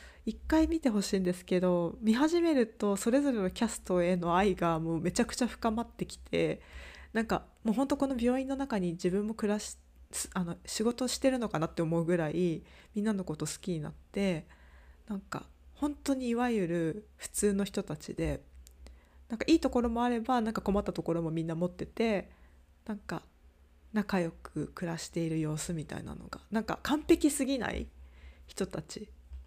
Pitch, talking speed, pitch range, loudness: 195 Hz, 345 characters per minute, 165-235 Hz, -32 LUFS